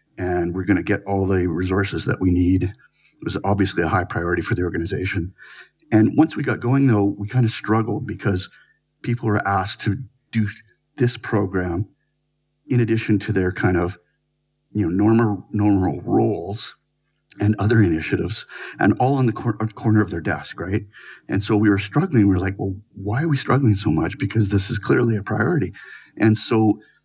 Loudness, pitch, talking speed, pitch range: -20 LUFS, 105 Hz, 190 wpm, 95-120 Hz